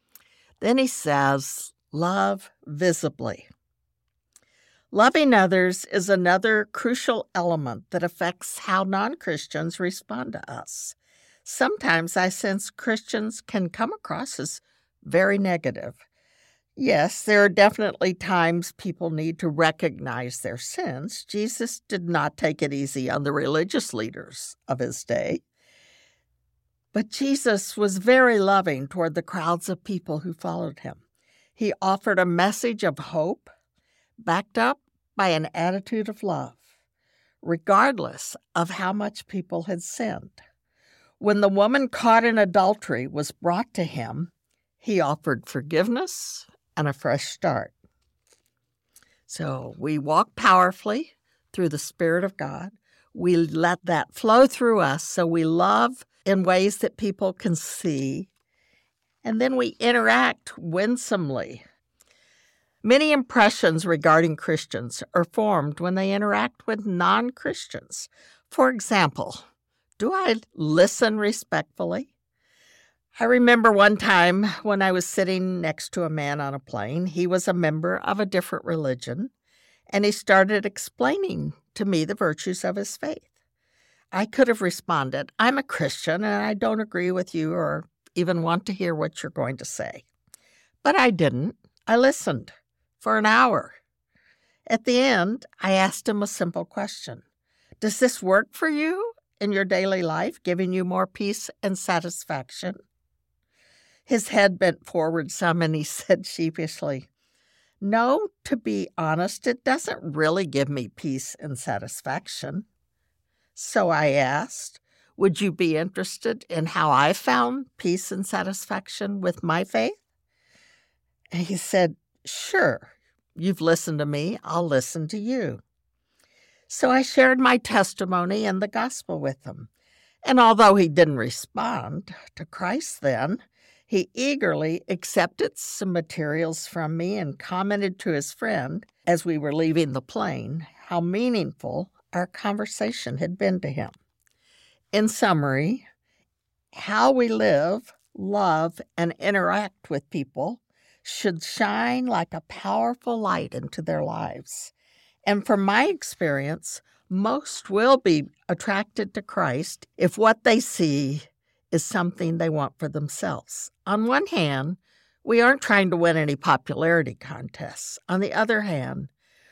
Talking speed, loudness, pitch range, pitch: 135 wpm, -24 LUFS, 160-215 Hz, 185 Hz